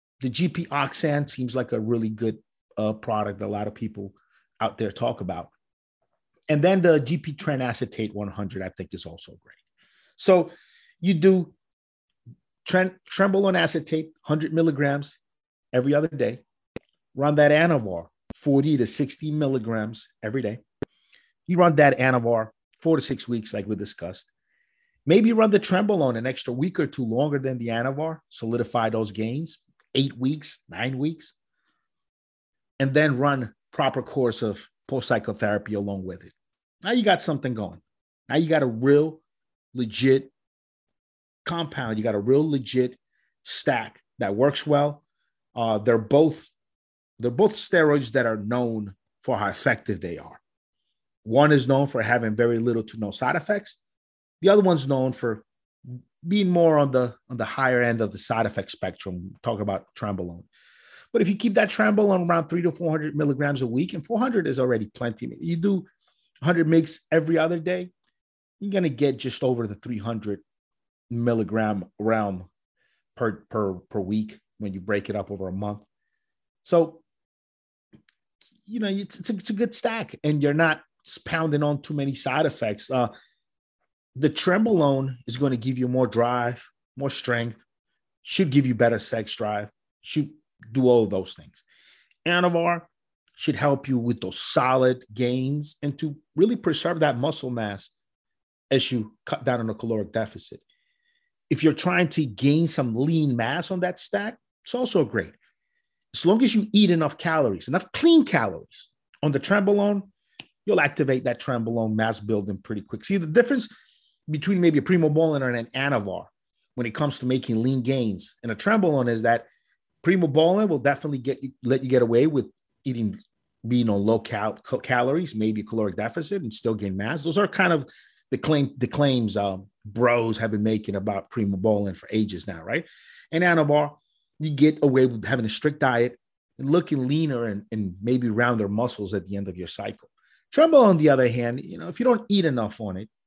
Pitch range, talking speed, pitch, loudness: 110-160 Hz, 175 wpm, 135 Hz, -24 LUFS